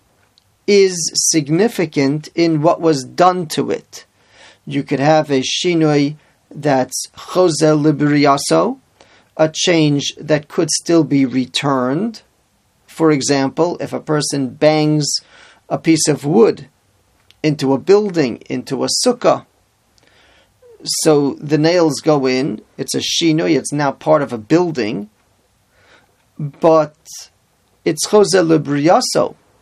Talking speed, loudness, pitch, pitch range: 115 wpm, -15 LUFS, 150 Hz, 140-165 Hz